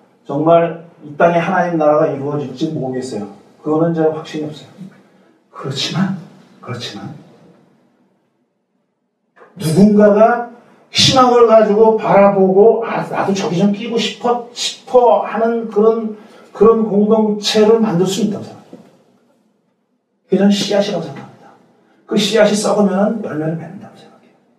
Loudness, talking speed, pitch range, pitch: -14 LUFS, 275 characters per minute, 170-225 Hz, 205 Hz